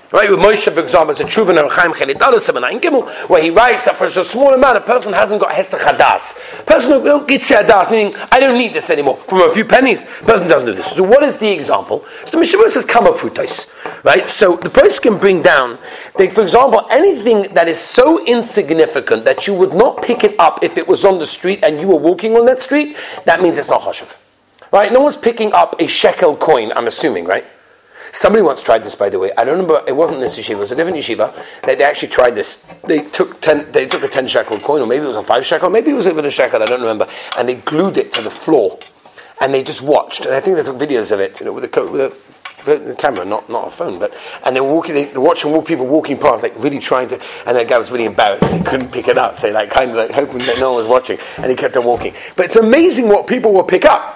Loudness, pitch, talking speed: -12 LUFS, 285 Hz, 255 wpm